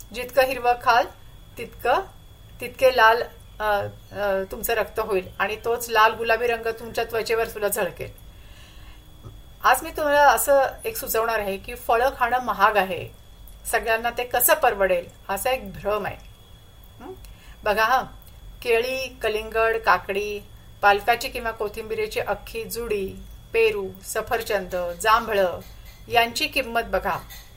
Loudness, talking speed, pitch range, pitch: -23 LUFS, 120 wpm, 195-245 Hz, 225 Hz